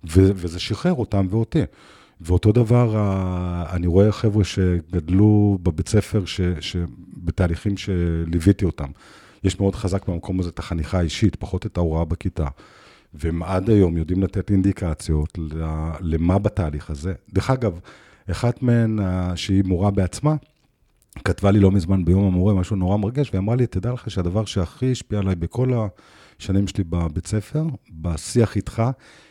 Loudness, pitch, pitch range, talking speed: -22 LUFS, 95 Hz, 90-105 Hz, 145 wpm